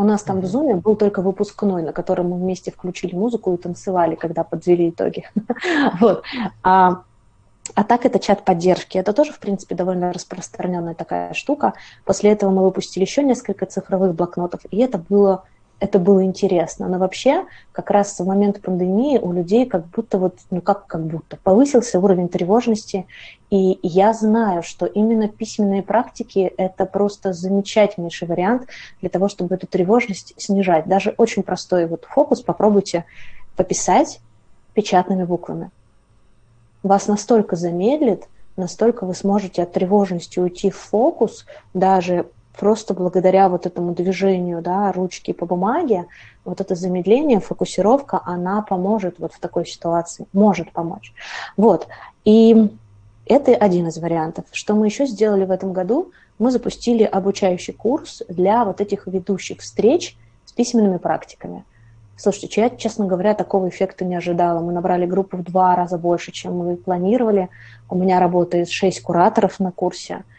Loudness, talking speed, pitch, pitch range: -19 LUFS, 150 wpm, 190 Hz, 175-210 Hz